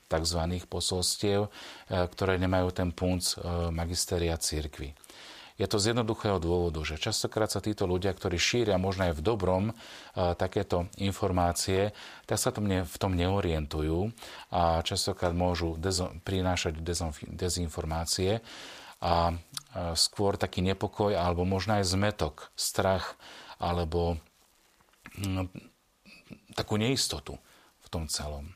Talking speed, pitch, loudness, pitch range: 110 wpm, 90 Hz, -30 LUFS, 85-100 Hz